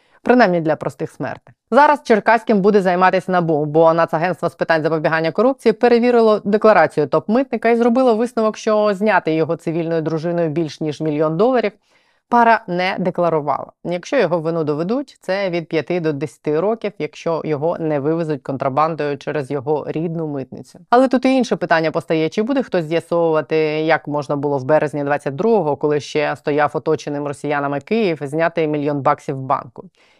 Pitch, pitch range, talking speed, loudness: 165 Hz, 150-210 Hz, 155 wpm, -17 LUFS